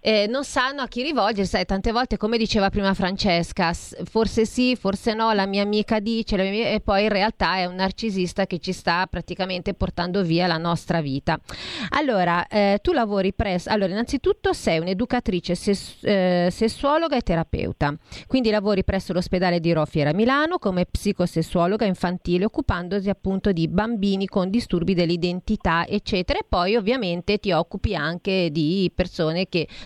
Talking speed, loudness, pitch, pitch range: 165 wpm, -23 LUFS, 195 Hz, 180-220 Hz